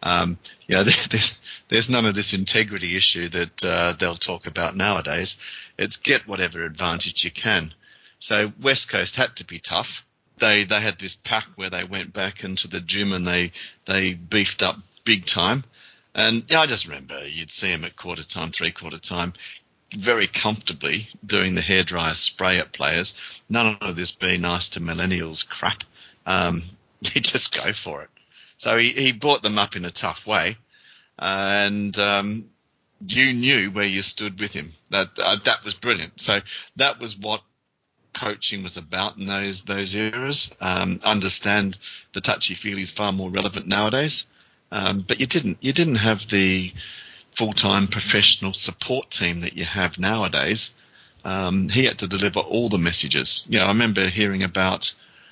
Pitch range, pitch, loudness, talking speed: 95-110 Hz, 100 Hz, -21 LUFS, 175 wpm